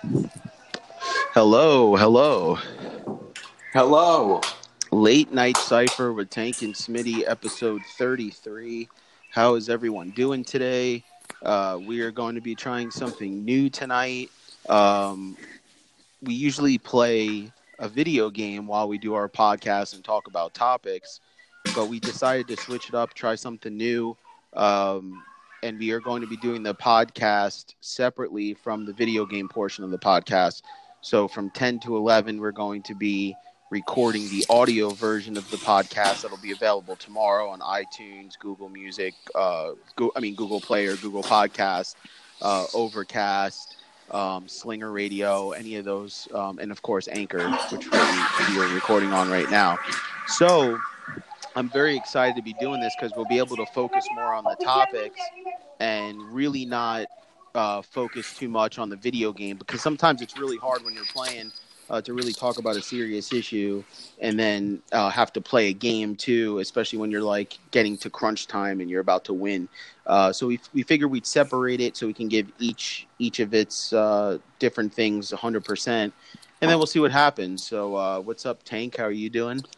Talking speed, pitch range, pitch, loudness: 170 wpm, 105-125 Hz, 110 Hz, -24 LUFS